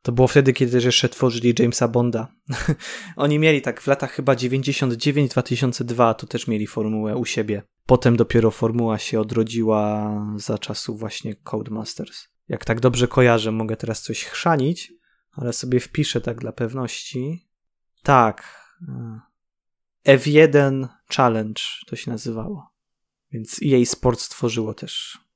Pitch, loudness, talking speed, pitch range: 120 Hz, -21 LUFS, 130 wpm, 115-135 Hz